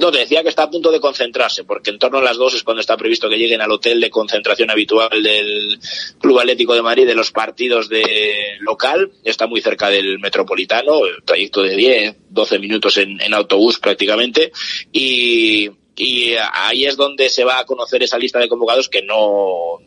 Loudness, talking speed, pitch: -14 LUFS, 195 wpm, 125 Hz